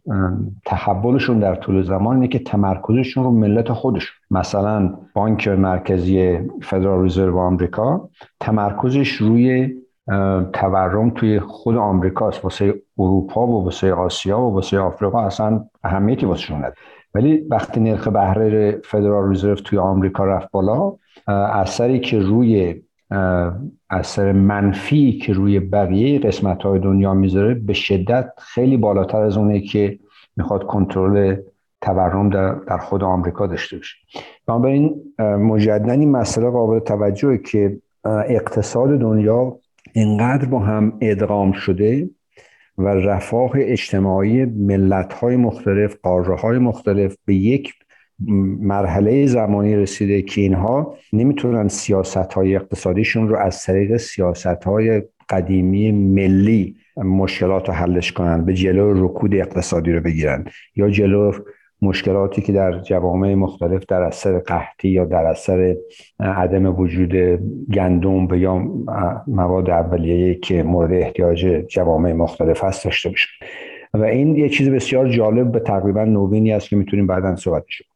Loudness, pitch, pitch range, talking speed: -18 LUFS, 100 Hz, 95-110 Hz, 130 wpm